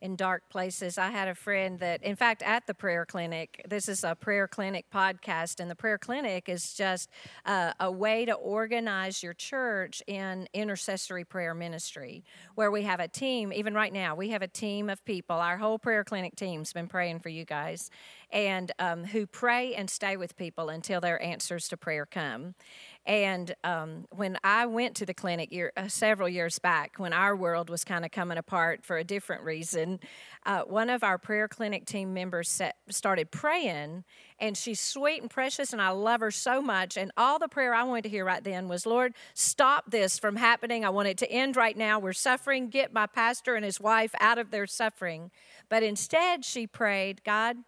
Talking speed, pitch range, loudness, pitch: 205 wpm, 180-220 Hz, -30 LUFS, 195 Hz